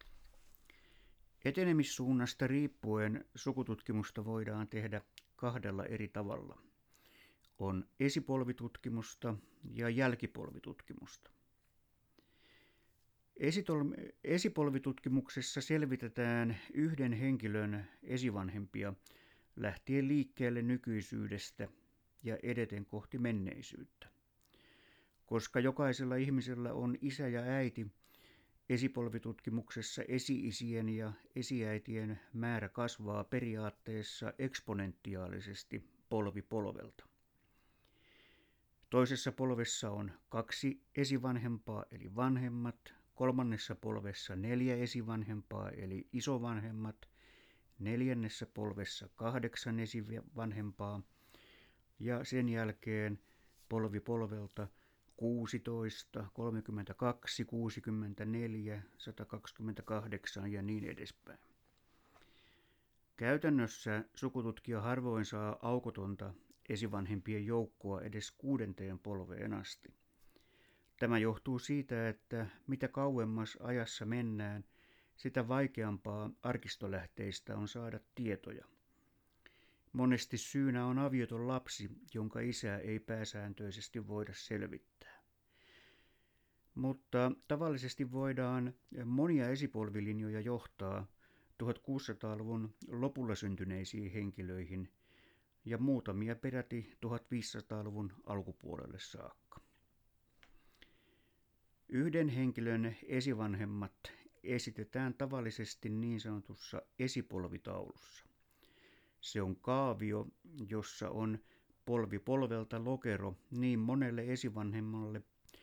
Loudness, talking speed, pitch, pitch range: -40 LUFS, 75 wpm, 115 Hz, 105-125 Hz